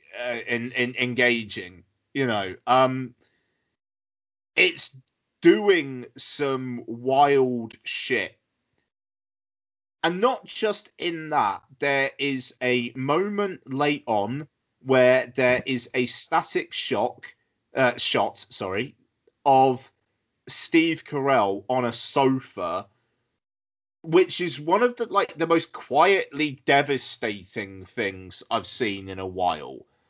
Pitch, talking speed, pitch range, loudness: 130 Hz, 110 wpm, 120-160 Hz, -24 LUFS